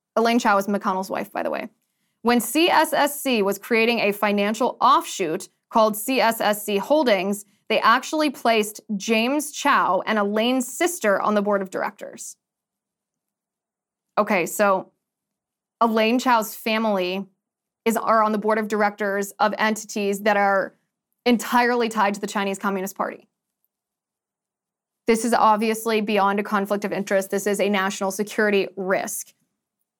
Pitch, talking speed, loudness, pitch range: 215 Hz, 135 wpm, -21 LUFS, 200-230 Hz